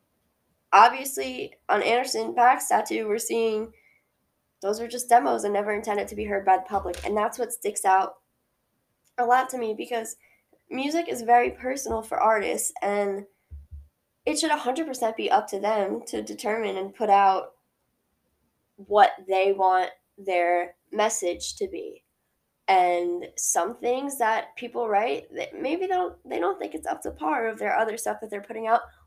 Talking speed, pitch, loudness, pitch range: 170 wpm, 210 Hz, -25 LUFS, 190-235 Hz